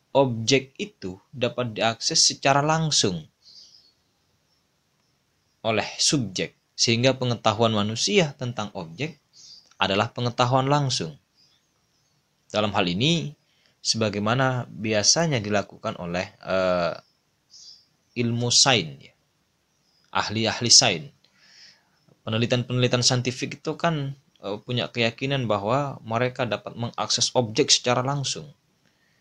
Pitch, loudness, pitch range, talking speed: 125 Hz, -23 LUFS, 110-145 Hz, 90 wpm